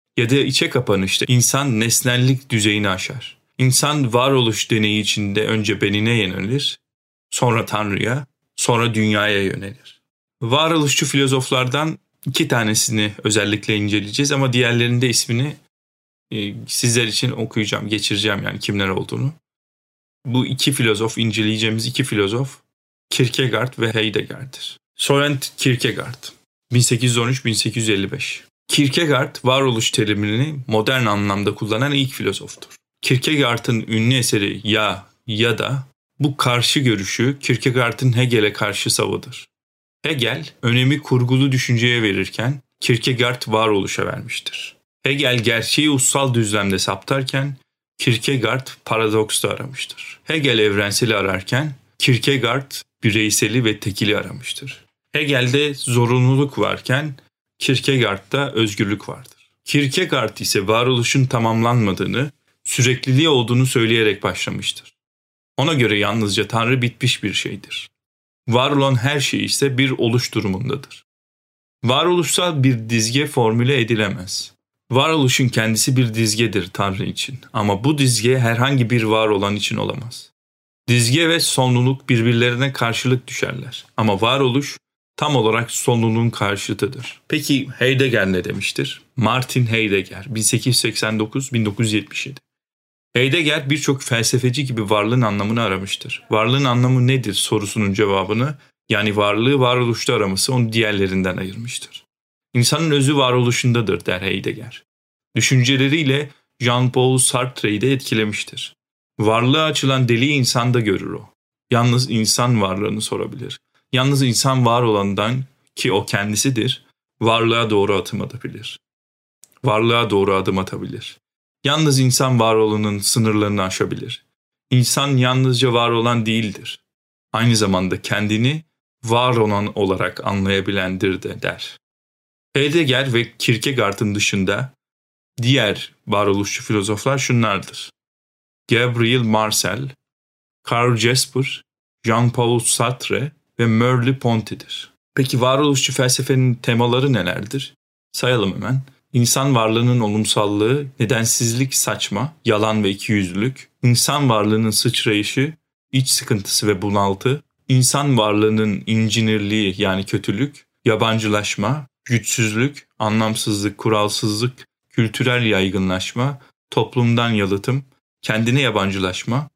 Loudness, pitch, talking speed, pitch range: -18 LUFS, 120 Hz, 105 wpm, 110-135 Hz